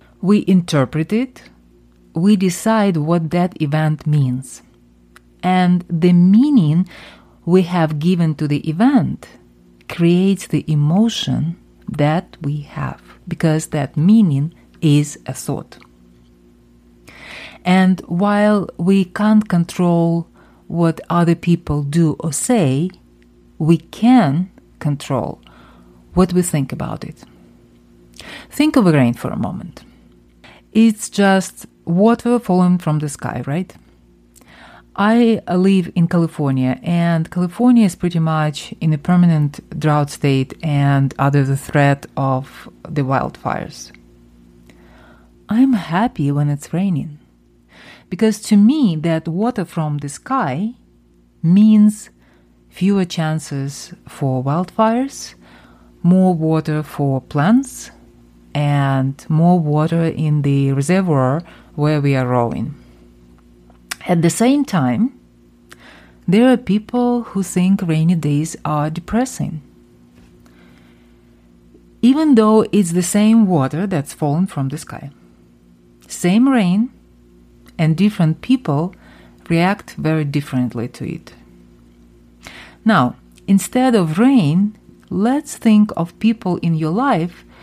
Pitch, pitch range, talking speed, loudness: 155 Hz, 120-185 Hz, 110 wpm, -16 LUFS